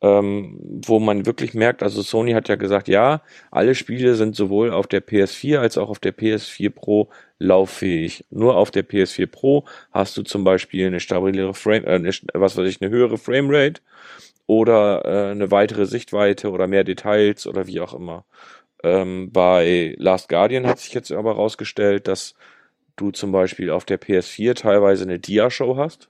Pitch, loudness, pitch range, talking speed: 100 Hz, -19 LUFS, 95-110 Hz, 175 wpm